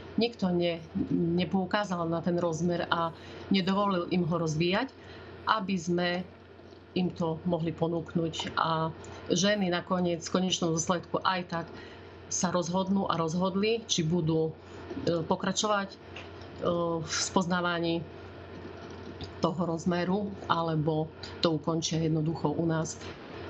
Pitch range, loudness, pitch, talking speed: 165-185 Hz, -30 LUFS, 170 Hz, 105 wpm